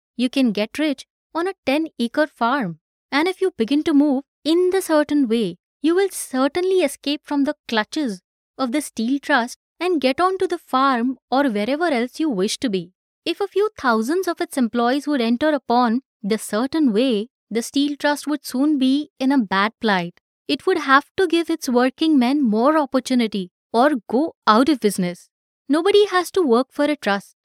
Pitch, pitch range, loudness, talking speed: 275 Hz, 235-310 Hz, -20 LUFS, 190 wpm